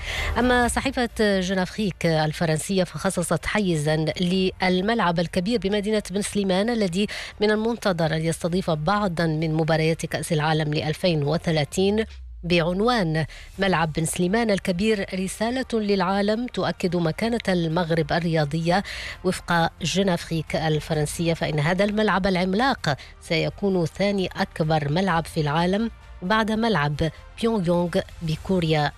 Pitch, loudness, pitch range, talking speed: 180 Hz, -23 LUFS, 160-200 Hz, 110 wpm